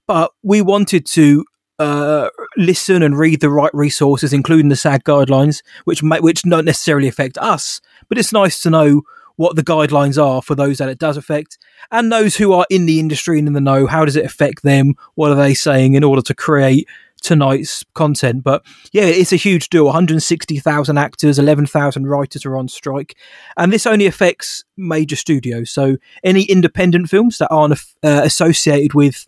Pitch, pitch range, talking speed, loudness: 150 Hz, 145-170 Hz, 195 wpm, -13 LUFS